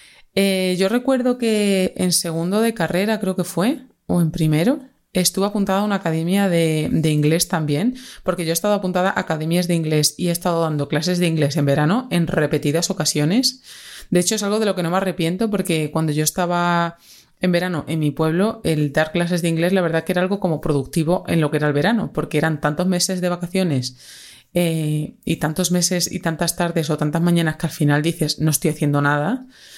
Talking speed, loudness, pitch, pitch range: 210 wpm, -20 LUFS, 175 Hz, 155-190 Hz